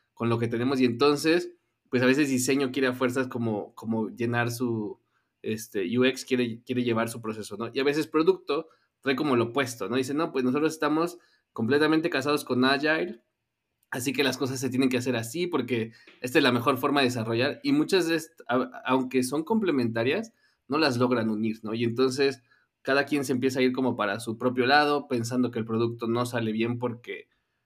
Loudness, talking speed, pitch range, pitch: -26 LUFS, 200 wpm, 120-145 Hz, 130 Hz